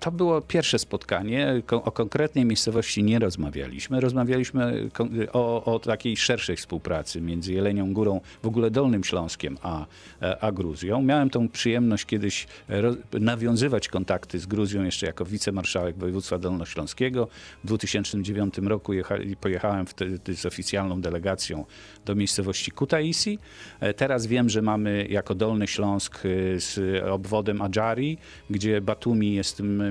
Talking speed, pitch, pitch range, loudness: 130 wpm, 105 Hz, 95-115 Hz, -26 LUFS